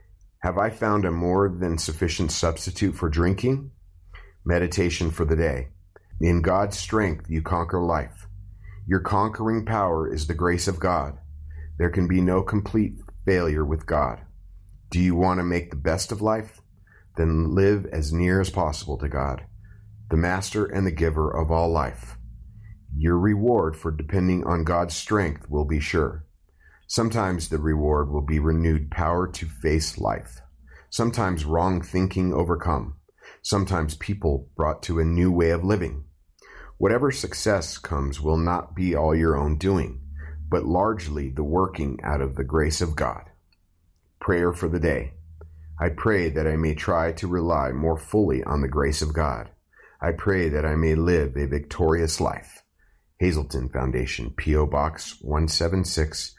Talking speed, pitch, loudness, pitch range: 155 wpm, 85 Hz, -24 LUFS, 75-95 Hz